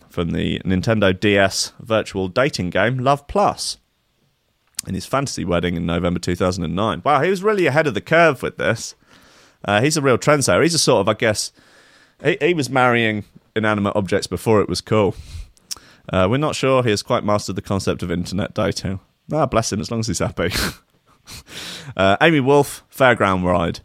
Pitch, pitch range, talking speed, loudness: 105 Hz, 90-125 Hz, 185 wpm, -19 LUFS